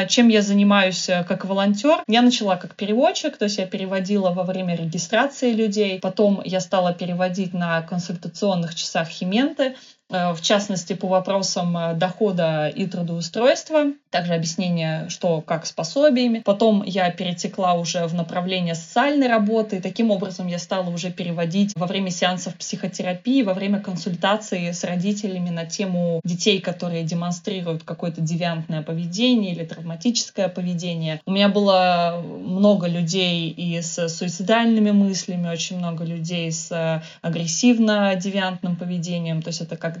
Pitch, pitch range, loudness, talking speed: 185 Hz, 170-205 Hz, -21 LUFS, 140 wpm